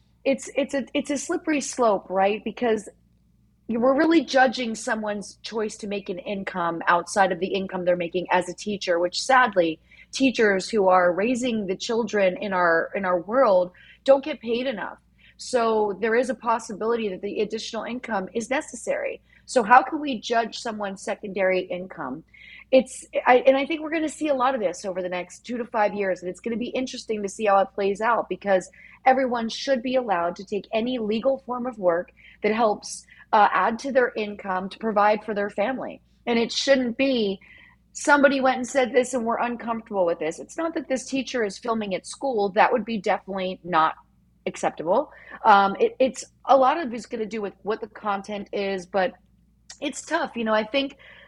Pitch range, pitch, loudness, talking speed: 195-255 Hz, 225 Hz, -24 LUFS, 200 wpm